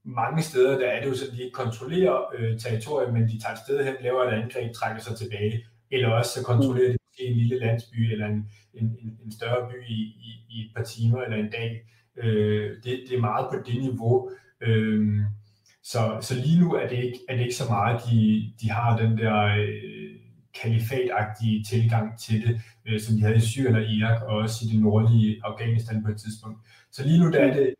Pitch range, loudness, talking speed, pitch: 110-125 Hz, -25 LUFS, 220 wpm, 115 Hz